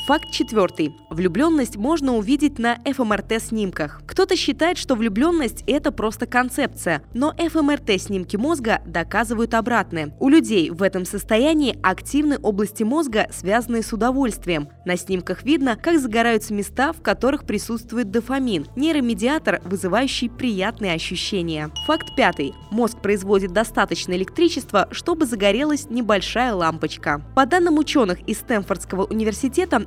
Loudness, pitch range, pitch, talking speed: -21 LUFS, 195-280 Hz, 230 Hz, 120 wpm